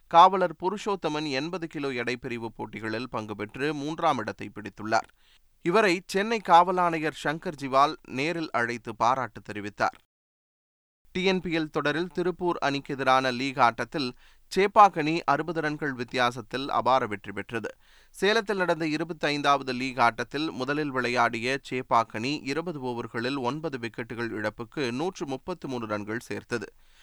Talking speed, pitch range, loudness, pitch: 115 wpm, 120-165 Hz, -27 LUFS, 135 Hz